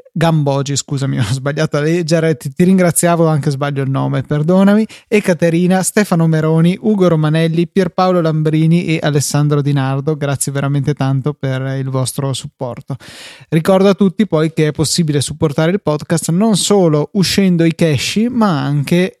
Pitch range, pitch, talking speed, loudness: 145-180 Hz, 160 Hz, 155 wpm, -14 LUFS